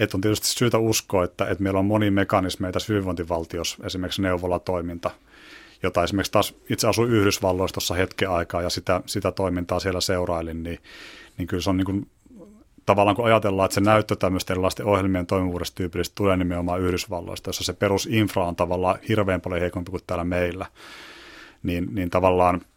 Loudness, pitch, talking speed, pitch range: -23 LUFS, 95 Hz, 170 wpm, 90-100 Hz